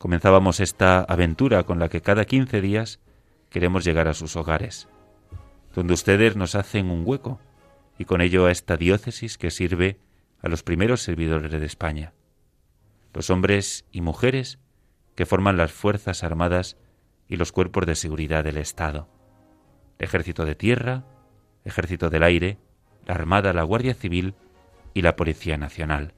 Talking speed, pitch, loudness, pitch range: 155 wpm, 90 Hz, -23 LUFS, 85-105 Hz